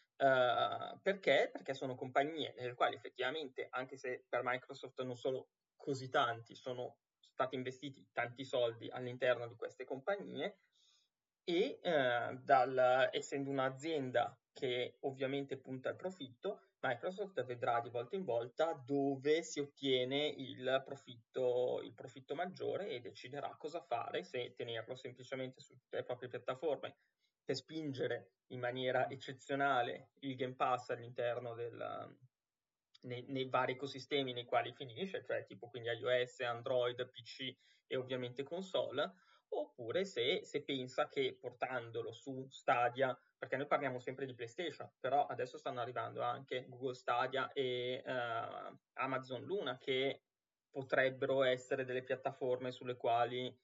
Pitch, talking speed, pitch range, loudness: 130 Hz, 130 wpm, 125-140 Hz, -40 LUFS